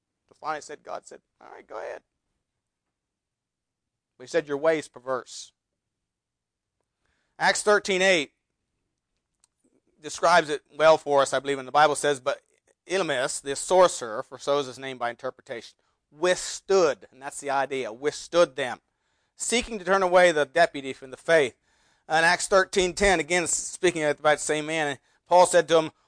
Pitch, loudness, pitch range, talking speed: 150 Hz, -24 LUFS, 135-180 Hz, 155 wpm